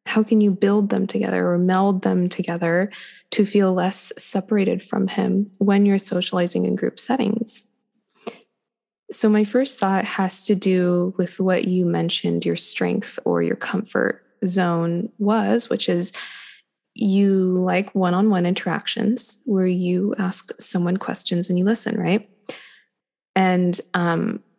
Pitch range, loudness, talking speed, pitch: 180-220 Hz, -20 LUFS, 145 wpm, 200 Hz